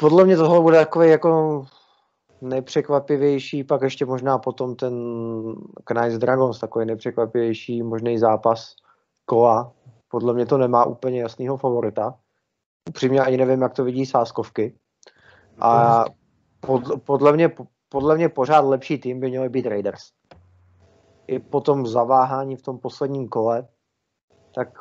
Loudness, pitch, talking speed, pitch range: -20 LUFS, 130 Hz, 130 wpm, 115-135 Hz